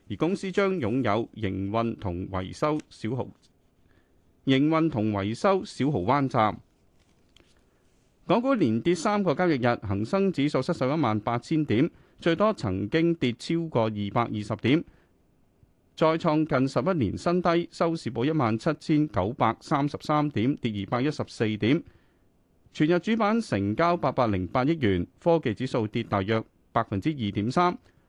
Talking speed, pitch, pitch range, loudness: 230 characters per minute, 125 Hz, 105-160 Hz, -26 LUFS